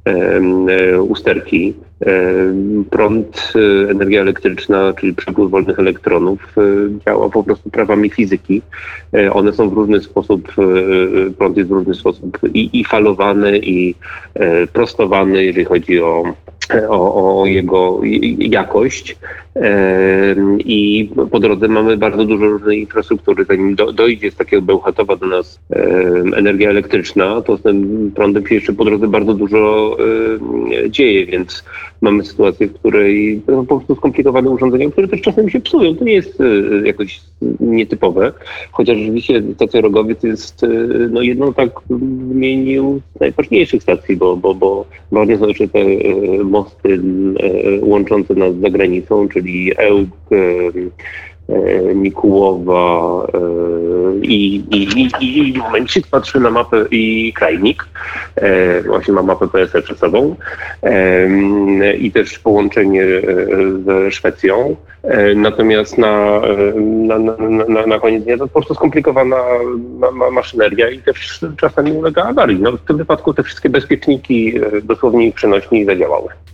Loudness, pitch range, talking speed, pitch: -13 LUFS, 95-120 Hz, 130 wpm, 105 Hz